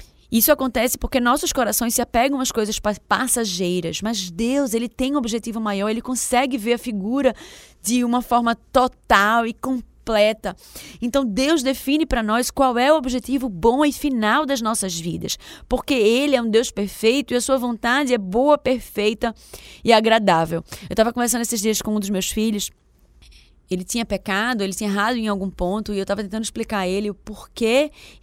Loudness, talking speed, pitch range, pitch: -20 LUFS, 185 wpm, 210-255 Hz, 230 Hz